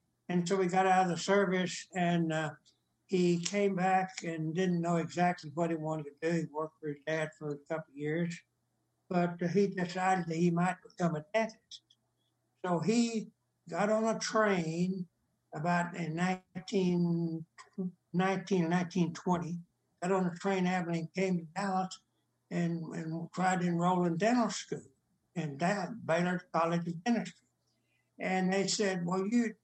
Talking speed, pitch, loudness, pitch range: 160 wpm, 180 Hz, -33 LUFS, 165-190 Hz